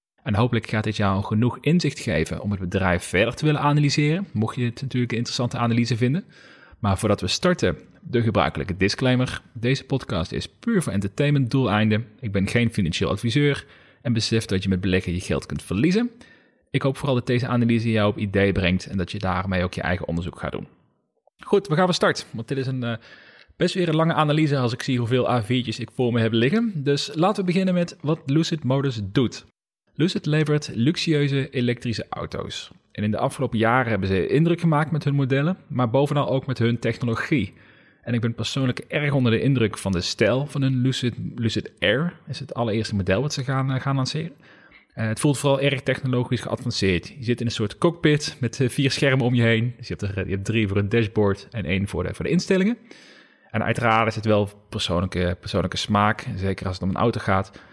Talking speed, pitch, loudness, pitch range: 215 wpm, 120 Hz, -23 LUFS, 105-140 Hz